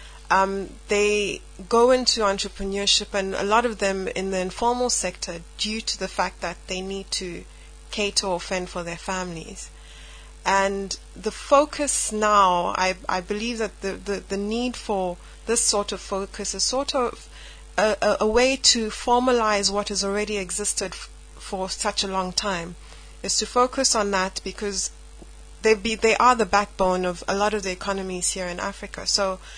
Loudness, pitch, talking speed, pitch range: -23 LUFS, 200 Hz, 175 wpm, 185-215 Hz